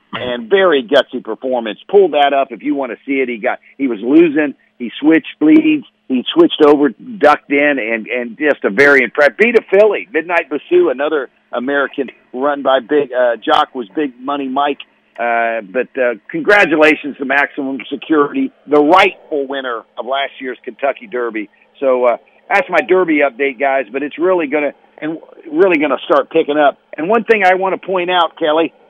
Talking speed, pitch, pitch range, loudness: 190 wpm, 145 Hz, 130-175 Hz, -14 LUFS